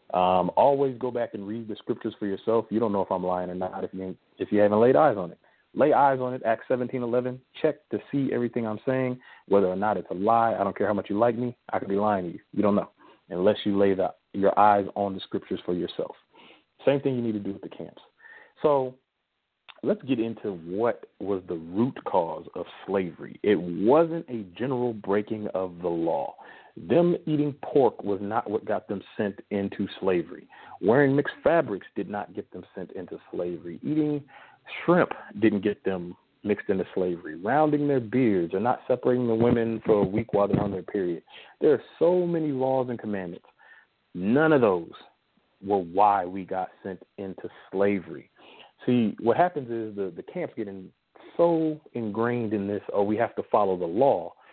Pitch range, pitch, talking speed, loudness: 100-130 Hz, 115 Hz, 200 wpm, -26 LUFS